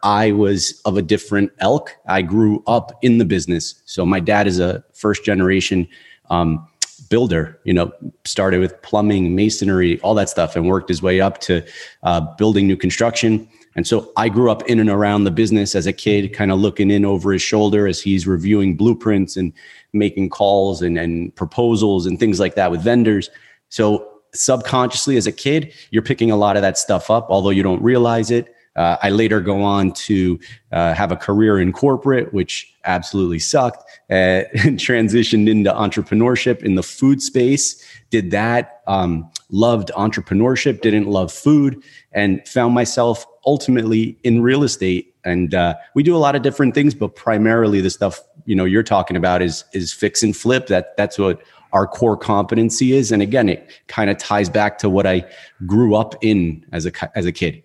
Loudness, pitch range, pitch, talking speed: -17 LUFS, 95-115 Hz, 105 Hz, 190 wpm